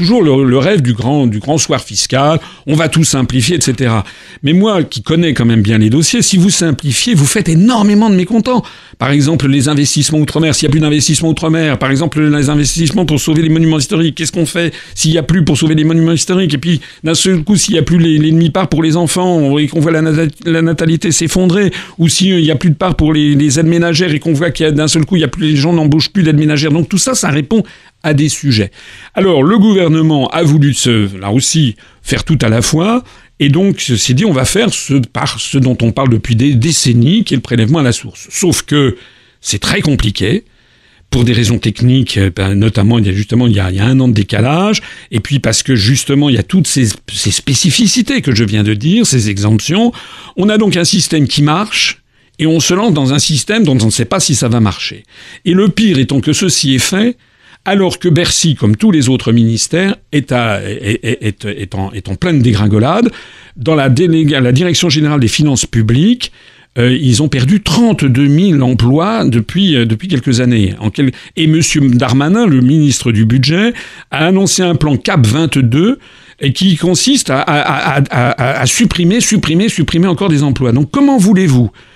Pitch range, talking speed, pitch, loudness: 125-170 Hz, 220 wpm, 150 Hz, -11 LUFS